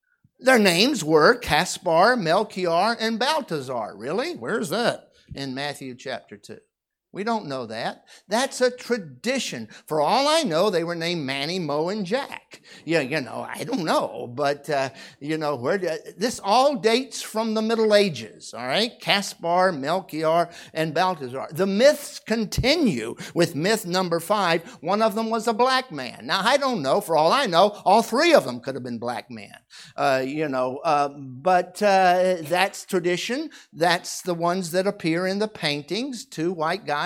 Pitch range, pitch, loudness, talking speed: 155-230 Hz, 185 Hz, -23 LUFS, 175 wpm